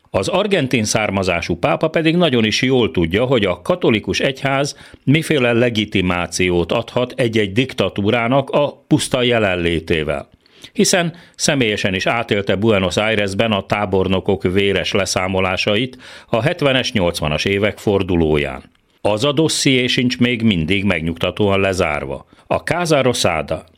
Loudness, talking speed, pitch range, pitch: -17 LUFS, 115 wpm, 95-130 Hz, 110 Hz